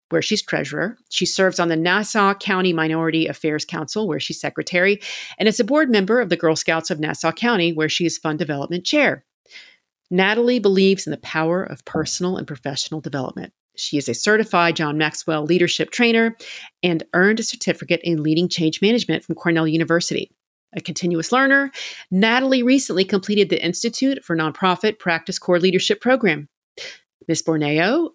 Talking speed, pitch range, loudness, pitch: 165 wpm, 160-215 Hz, -19 LUFS, 175 Hz